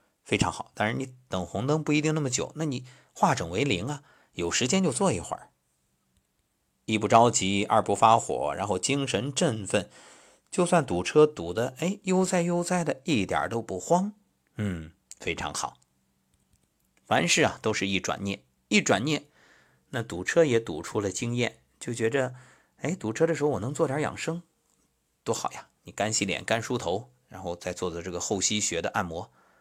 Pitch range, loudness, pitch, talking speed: 95-150 Hz, -27 LUFS, 120 Hz, 250 characters per minute